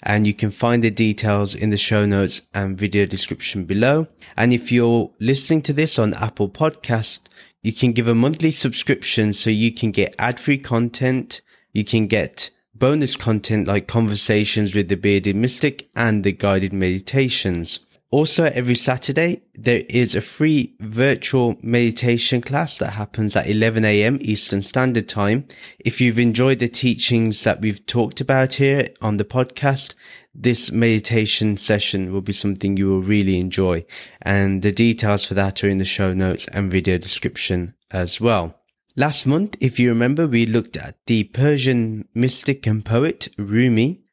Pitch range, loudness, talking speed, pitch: 100-125 Hz, -19 LUFS, 165 wpm, 115 Hz